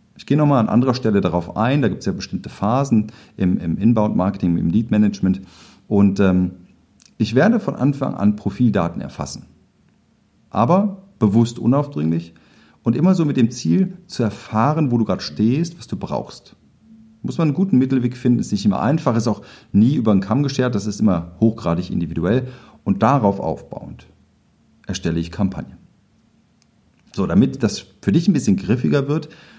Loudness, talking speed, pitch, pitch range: -19 LUFS, 170 wpm, 110 Hz, 95-130 Hz